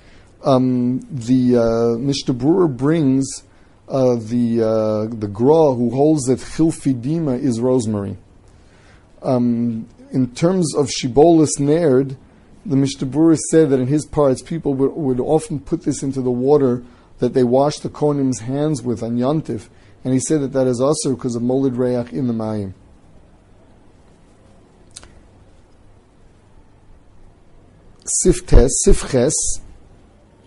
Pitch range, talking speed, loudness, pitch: 100-140 Hz, 120 wpm, -18 LUFS, 125 Hz